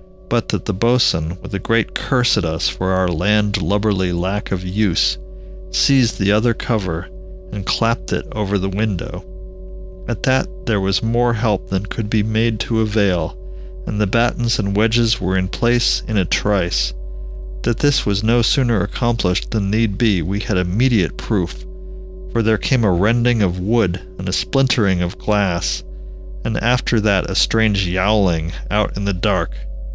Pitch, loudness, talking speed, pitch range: 105 Hz, -18 LUFS, 170 wpm, 95-115 Hz